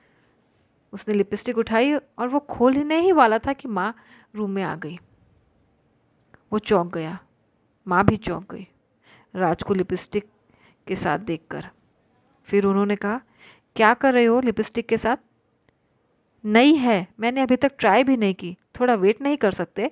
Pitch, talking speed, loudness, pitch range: 210 Hz, 155 wpm, -22 LUFS, 185-245 Hz